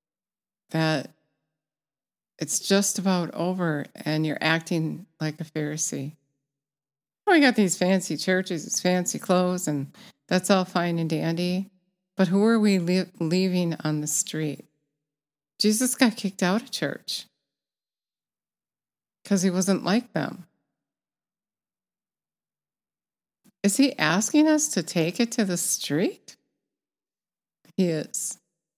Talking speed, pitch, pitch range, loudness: 120 wpm, 180 Hz, 155-195 Hz, -24 LUFS